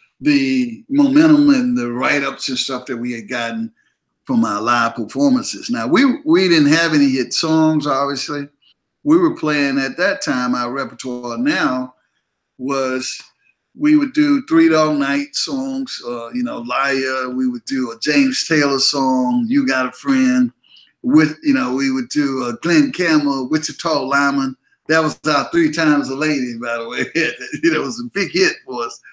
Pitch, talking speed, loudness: 150 Hz, 175 wpm, -17 LUFS